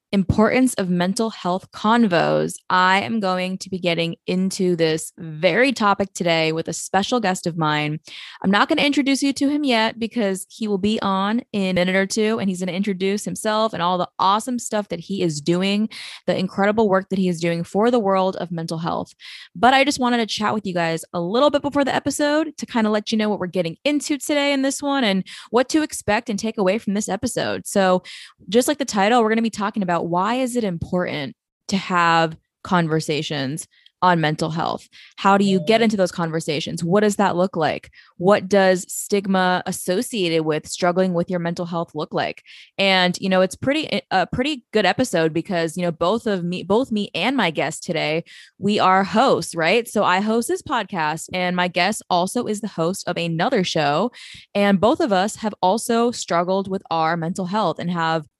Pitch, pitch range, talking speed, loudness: 190 Hz, 175-225 Hz, 210 wpm, -20 LUFS